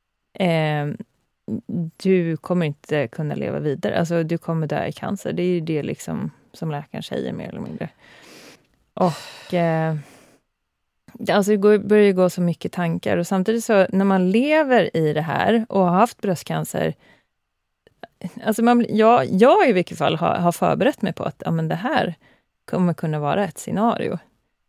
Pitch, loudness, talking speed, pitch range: 180 Hz, -21 LUFS, 165 wpm, 160-210 Hz